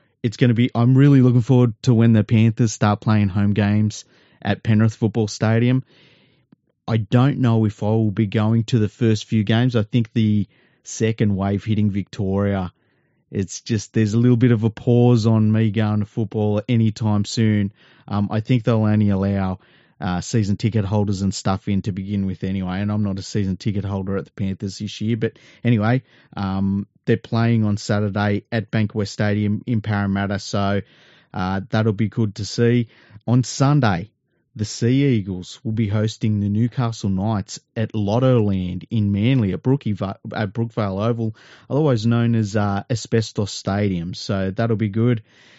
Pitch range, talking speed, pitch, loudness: 100-115 Hz, 180 wpm, 110 Hz, -20 LUFS